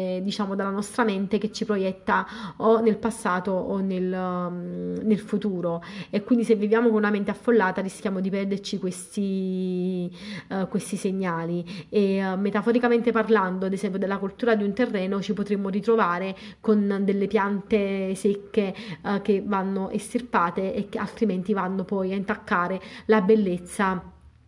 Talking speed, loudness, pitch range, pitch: 150 wpm, -25 LUFS, 190-215 Hz, 200 Hz